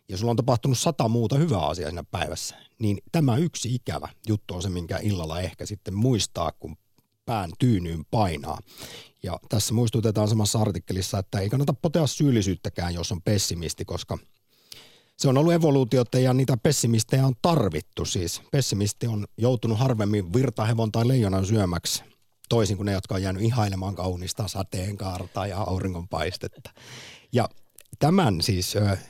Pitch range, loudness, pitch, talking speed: 95-125 Hz, -25 LUFS, 110 Hz, 150 wpm